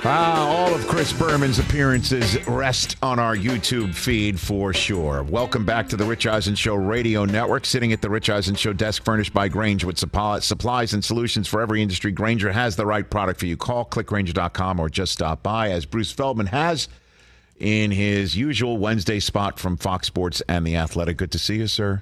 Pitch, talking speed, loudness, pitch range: 105 Hz, 195 wpm, -22 LUFS, 100-120 Hz